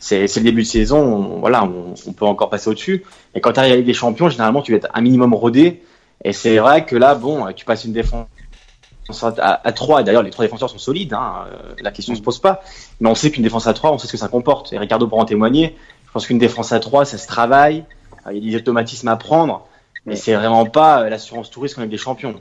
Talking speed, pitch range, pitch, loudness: 260 wpm, 110-140 Hz, 115 Hz, -16 LUFS